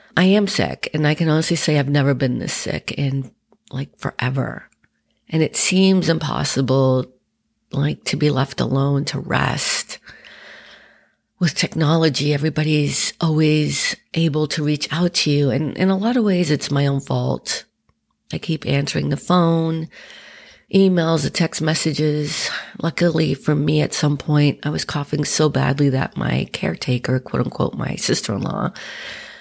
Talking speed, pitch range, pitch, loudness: 155 wpm, 140-165 Hz, 150 Hz, -19 LUFS